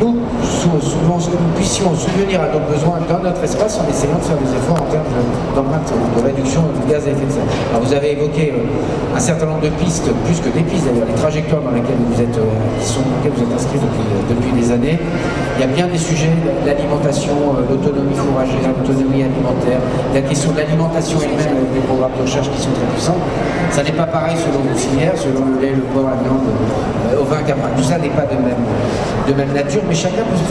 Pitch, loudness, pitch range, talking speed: 140 Hz, -16 LUFS, 130-155 Hz, 225 wpm